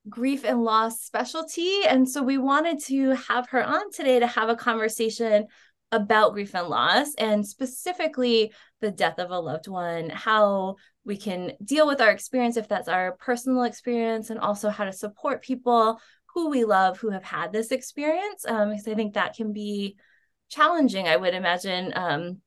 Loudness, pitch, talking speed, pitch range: -25 LUFS, 225 Hz, 180 wpm, 205-260 Hz